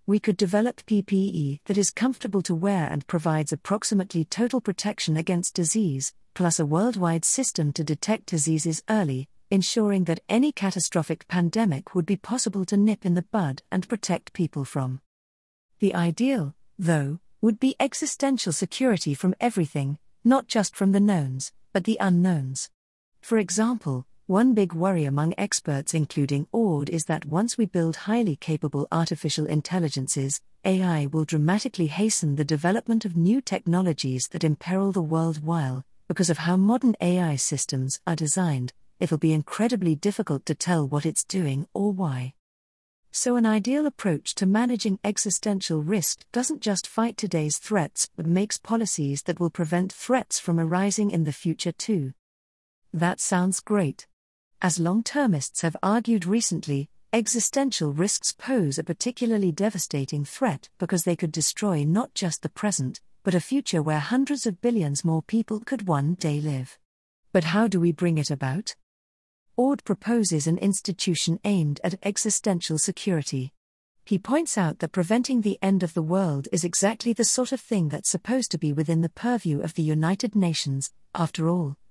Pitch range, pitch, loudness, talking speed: 155-210 Hz, 180 Hz, -25 LUFS, 160 wpm